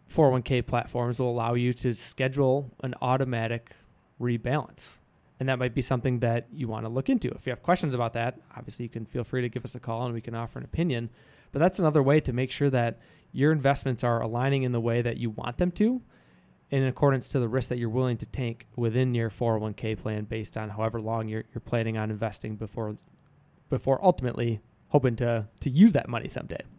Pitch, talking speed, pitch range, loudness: 125 Hz, 215 wpm, 115-135 Hz, -28 LUFS